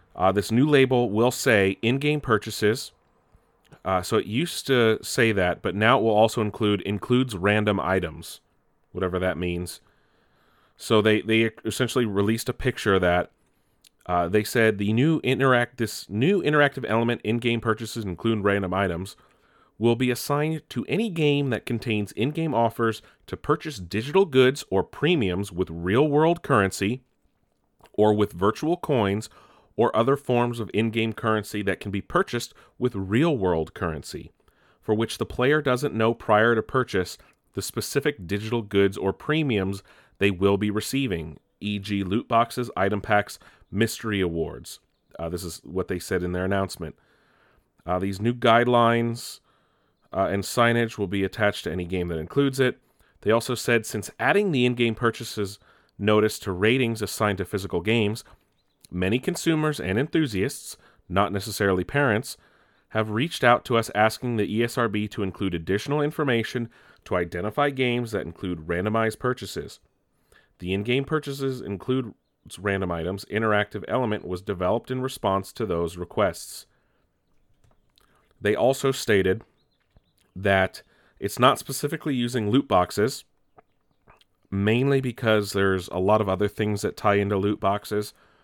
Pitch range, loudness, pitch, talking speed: 100-125 Hz, -24 LUFS, 110 Hz, 150 wpm